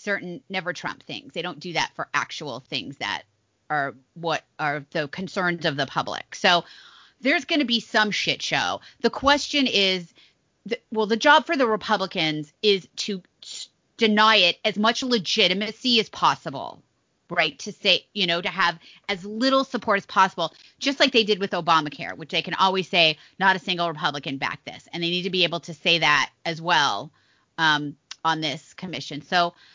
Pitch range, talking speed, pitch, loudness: 165-215 Hz, 190 wpm, 185 Hz, -23 LUFS